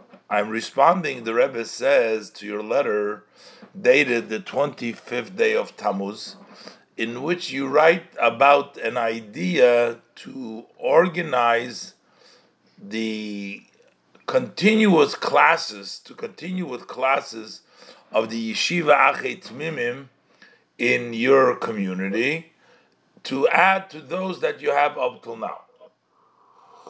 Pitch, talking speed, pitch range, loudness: 135 Hz, 110 wpm, 115-185 Hz, -21 LUFS